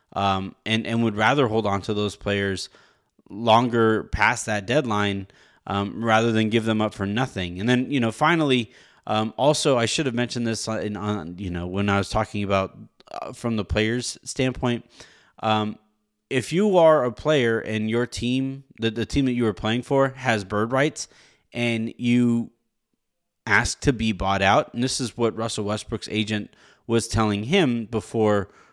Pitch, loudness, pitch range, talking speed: 110 Hz, -23 LUFS, 105-120 Hz, 180 wpm